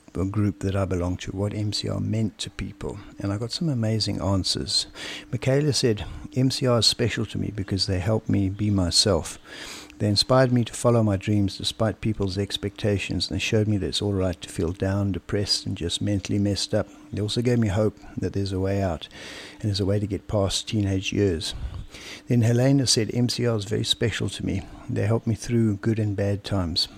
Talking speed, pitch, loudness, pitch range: 205 wpm, 100 Hz, -24 LUFS, 95-115 Hz